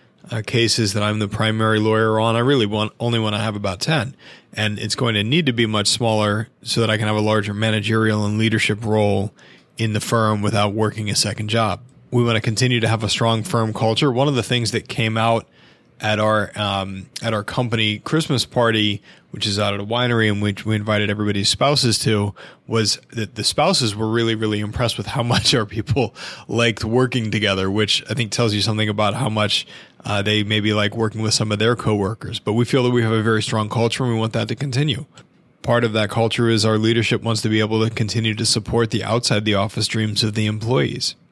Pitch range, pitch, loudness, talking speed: 105-115 Hz, 110 Hz, -19 LUFS, 230 wpm